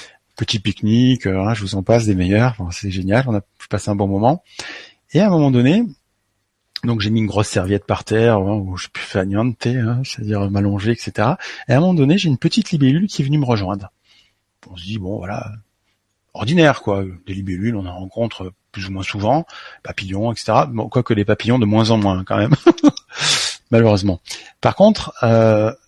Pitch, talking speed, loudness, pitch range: 110 Hz, 195 wpm, -17 LUFS, 100-125 Hz